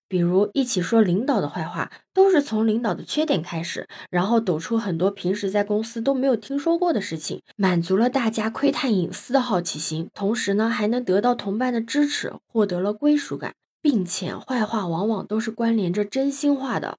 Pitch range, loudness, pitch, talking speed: 190-255 Hz, -23 LUFS, 220 Hz, 305 characters per minute